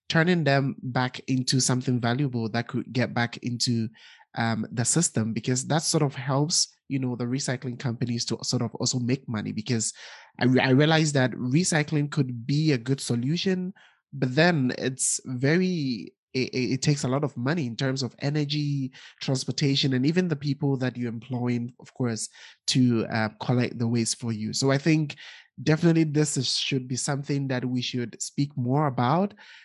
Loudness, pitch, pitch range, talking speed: -26 LUFS, 130 Hz, 120-145 Hz, 180 wpm